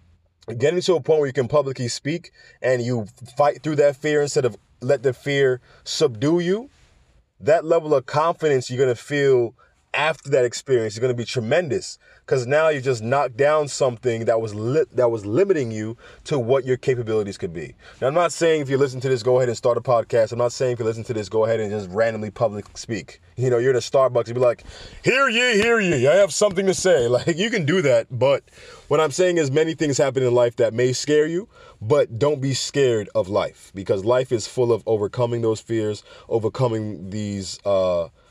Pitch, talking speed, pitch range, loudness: 130 Hz, 225 wpm, 115-150 Hz, -21 LUFS